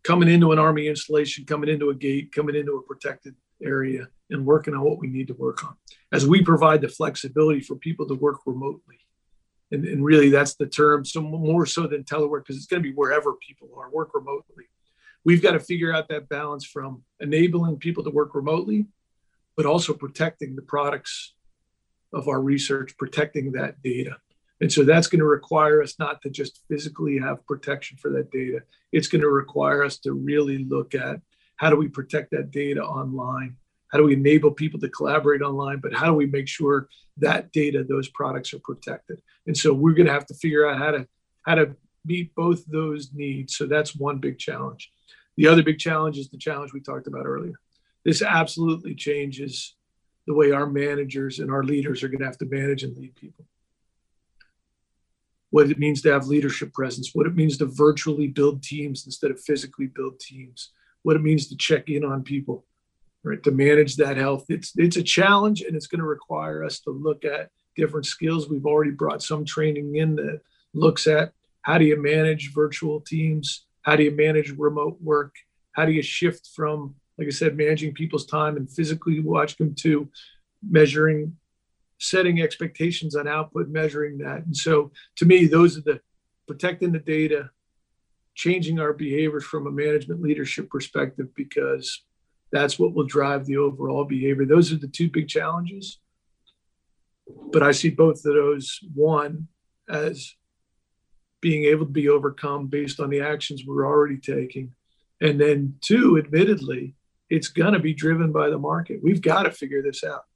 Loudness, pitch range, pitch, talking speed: -22 LUFS, 140-155 Hz, 150 Hz, 185 wpm